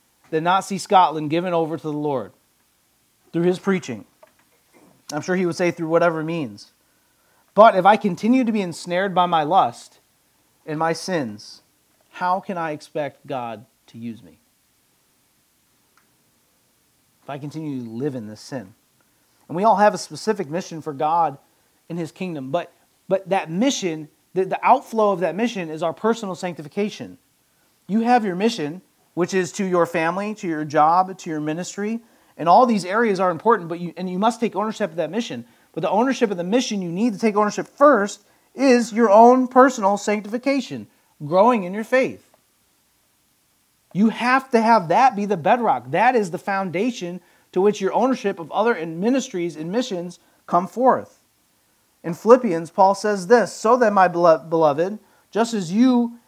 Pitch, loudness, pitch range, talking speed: 190 Hz, -20 LUFS, 165-225 Hz, 175 wpm